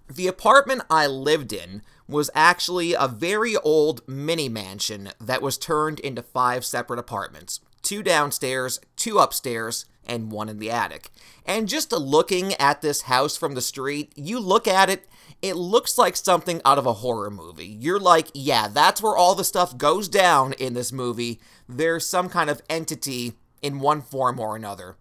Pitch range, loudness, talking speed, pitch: 120-165 Hz, -22 LUFS, 175 wpm, 140 Hz